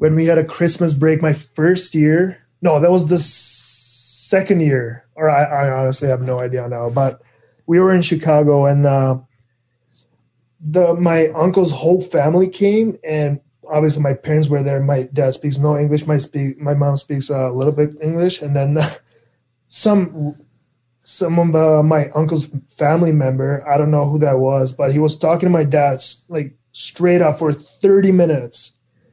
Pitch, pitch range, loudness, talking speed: 145 Hz, 130-160 Hz, -16 LUFS, 170 wpm